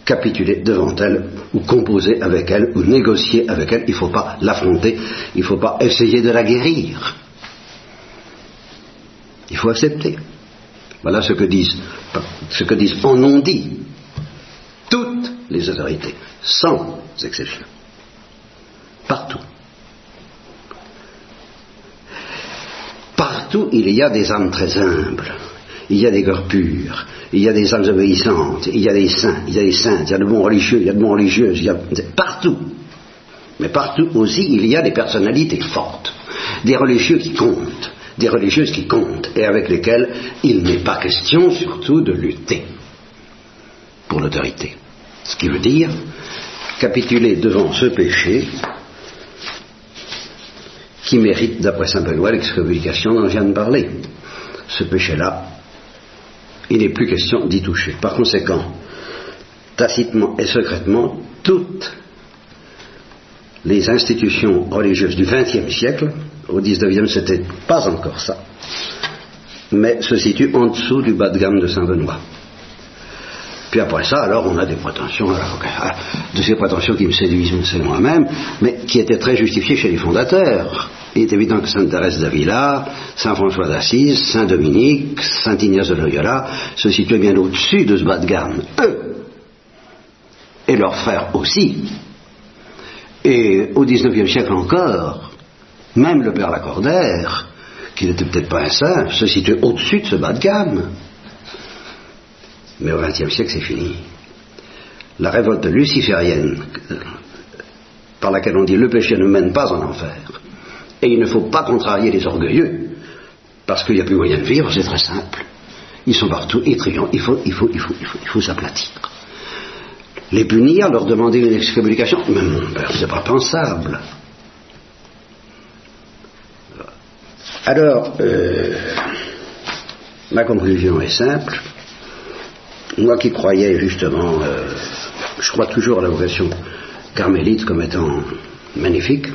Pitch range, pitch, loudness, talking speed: 95-120 Hz, 110 Hz, -15 LUFS, 145 wpm